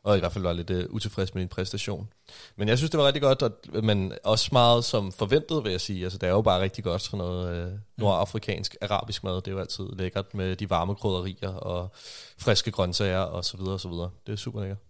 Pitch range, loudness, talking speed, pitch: 90-110 Hz, -27 LUFS, 225 wpm, 100 Hz